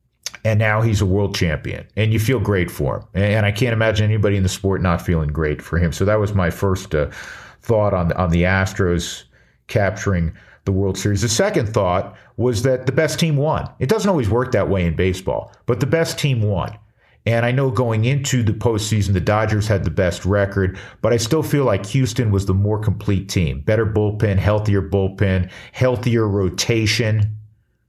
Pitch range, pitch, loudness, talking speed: 95-115 Hz, 105 Hz, -19 LUFS, 200 wpm